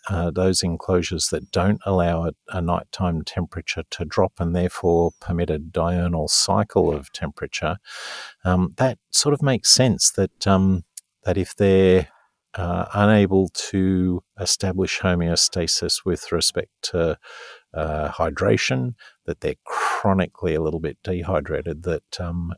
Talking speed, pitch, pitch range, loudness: 135 wpm, 90 Hz, 85-95 Hz, -21 LUFS